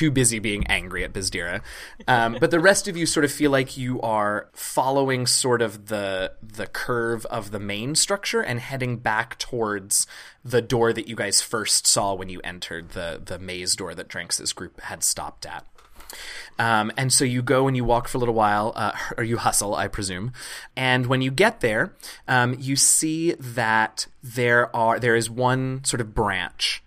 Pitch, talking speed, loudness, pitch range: 120 Hz, 195 wpm, -22 LUFS, 105-130 Hz